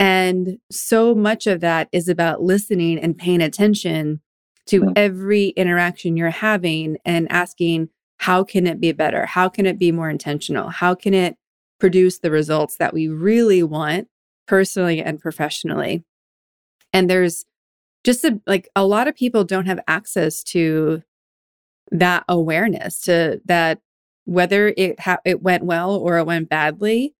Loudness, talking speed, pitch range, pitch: -18 LUFS, 150 wpm, 165-195 Hz, 180 Hz